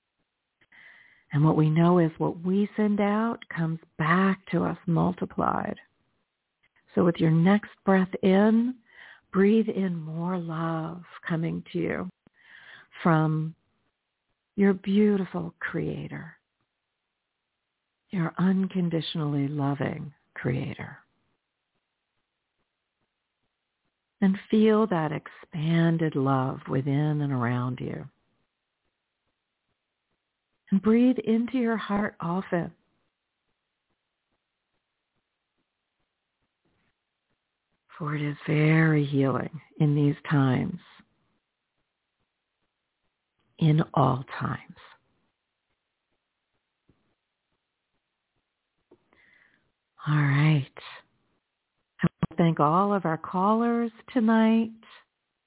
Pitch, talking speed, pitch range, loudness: 165 Hz, 80 wpm, 150-200 Hz, -26 LUFS